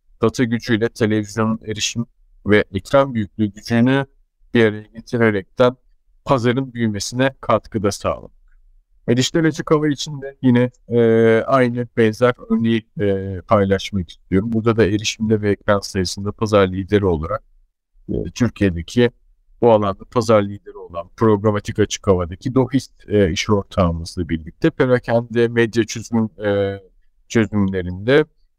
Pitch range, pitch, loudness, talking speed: 100-120 Hz, 110 Hz, -19 LUFS, 115 wpm